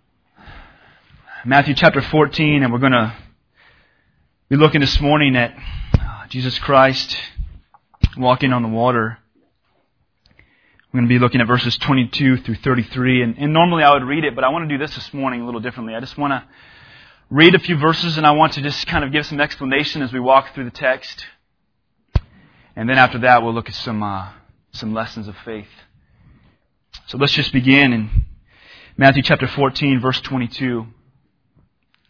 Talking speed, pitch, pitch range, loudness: 175 wpm, 130 Hz, 120-145 Hz, -16 LUFS